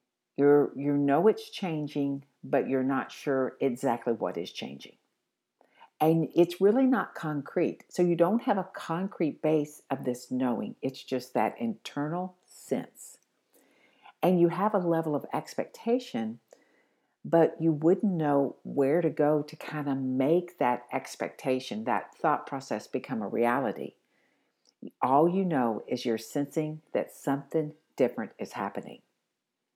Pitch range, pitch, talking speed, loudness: 135-175 Hz, 150 Hz, 140 wpm, -29 LUFS